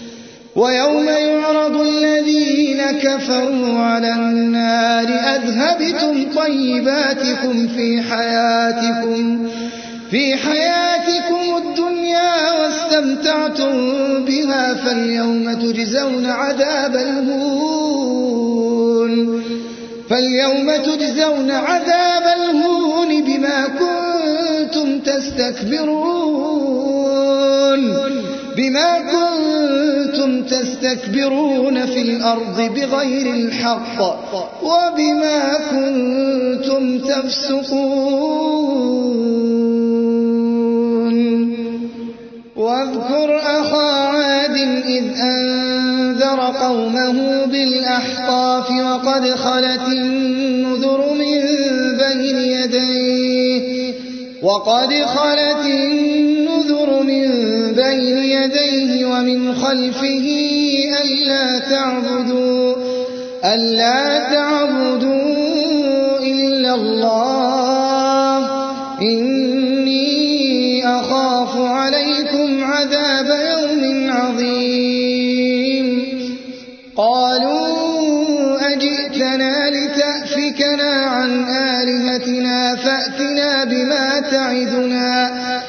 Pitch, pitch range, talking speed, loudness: 265 Hz, 250-285 Hz, 55 wpm, -16 LUFS